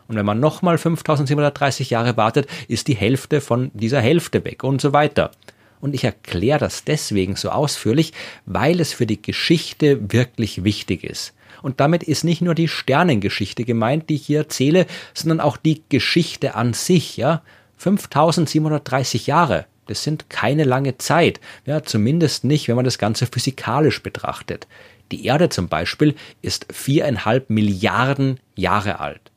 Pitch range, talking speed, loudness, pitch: 115-155 Hz, 155 wpm, -19 LUFS, 135 Hz